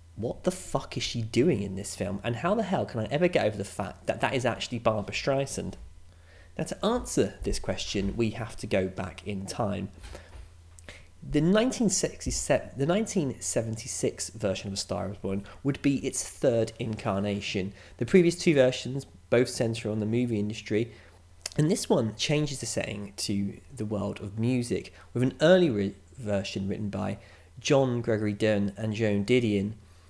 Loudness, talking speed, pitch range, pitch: -29 LUFS, 170 wpm, 95-125 Hz, 105 Hz